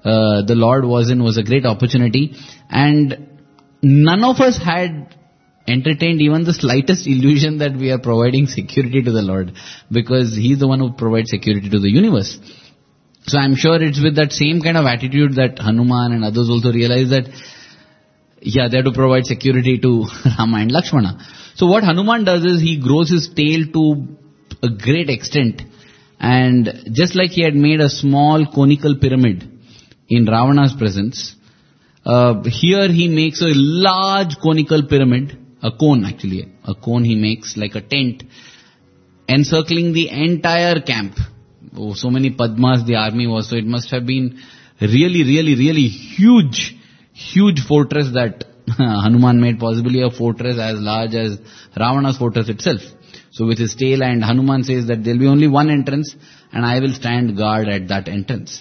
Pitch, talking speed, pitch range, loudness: 130 Hz, 170 wpm, 115-150 Hz, -15 LUFS